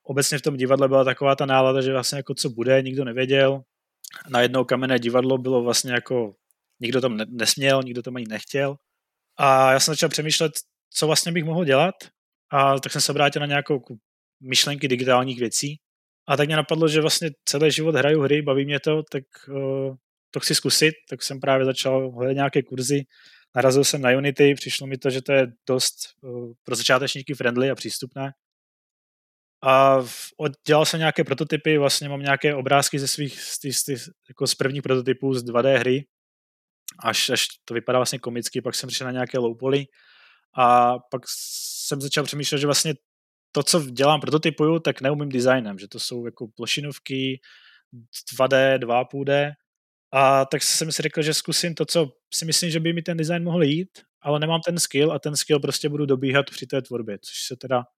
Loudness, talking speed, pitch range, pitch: -22 LUFS, 185 wpm, 130-150 Hz, 135 Hz